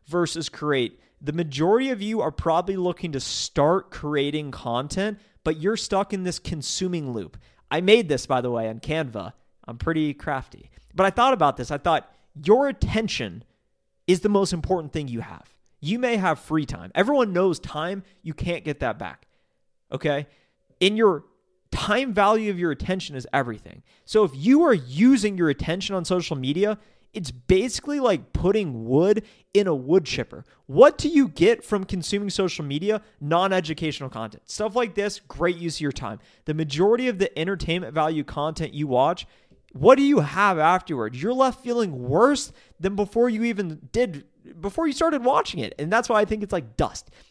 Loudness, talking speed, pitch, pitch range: -23 LUFS, 185 wpm, 175 Hz, 145-210 Hz